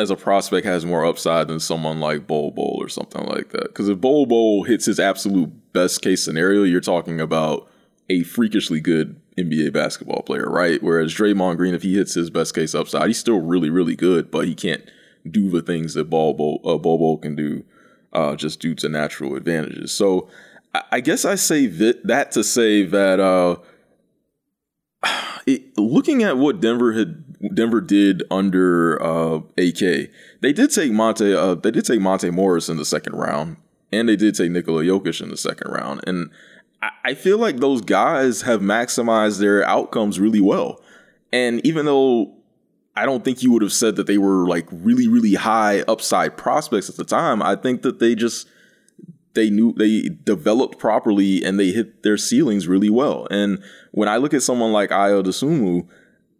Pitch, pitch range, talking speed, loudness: 100 Hz, 90-115 Hz, 185 wpm, -19 LUFS